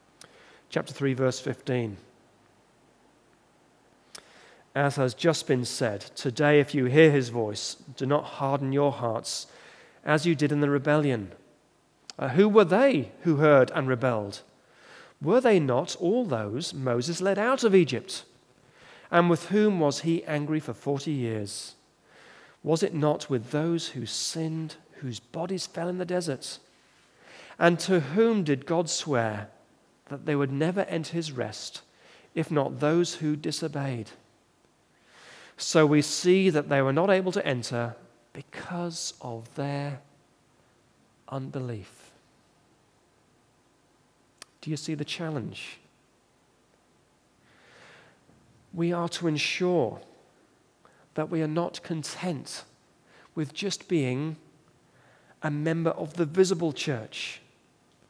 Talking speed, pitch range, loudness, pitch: 125 wpm, 130-170 Hz, -27 LUFS, 150 Hz